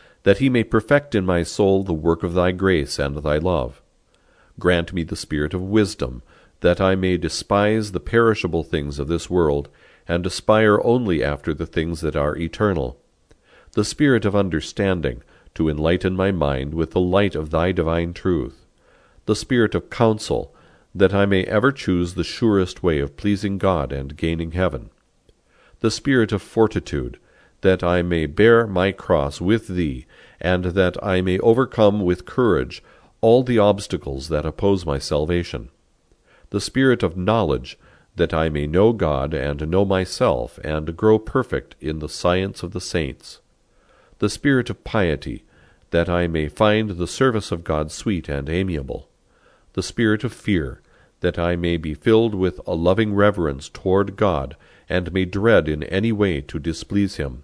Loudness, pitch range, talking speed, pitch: -21 LUFS, 80-105 Hz, 165 wpm, 90 Hz